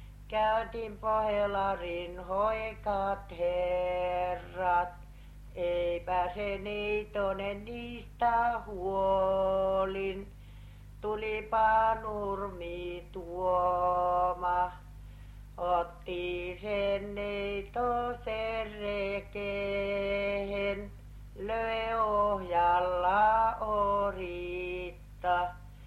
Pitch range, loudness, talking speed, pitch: 180-210 Hz, -32 LUFS, 40 wpm, 195 Hz